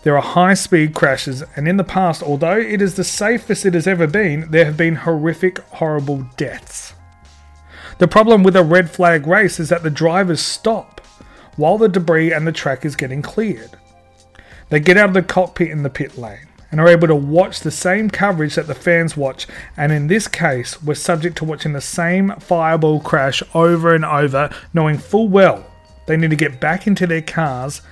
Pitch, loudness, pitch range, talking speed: 165 Hz, -15 LUFS, 145-185 Hz, 200 wpm